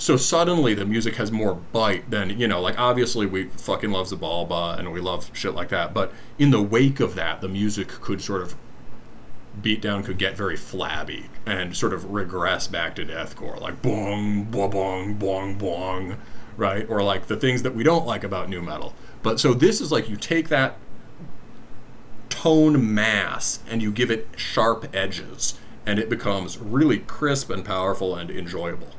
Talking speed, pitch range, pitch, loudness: 185 wpm, 95-120 Hz, 105 Hz, -24 LUFS